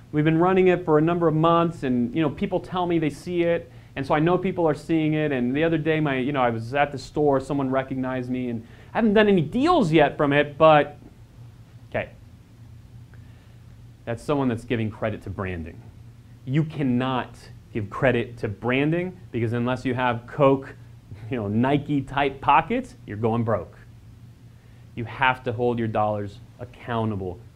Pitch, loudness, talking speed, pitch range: 125 Hz, -23 LUFS, 185 wpm, 115-150 Hz